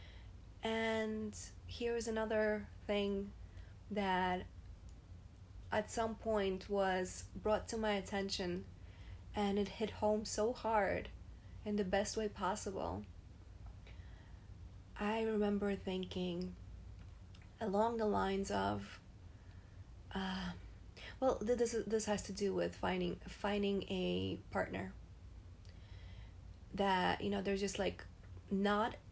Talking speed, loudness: 110 wpm, -39 LUFS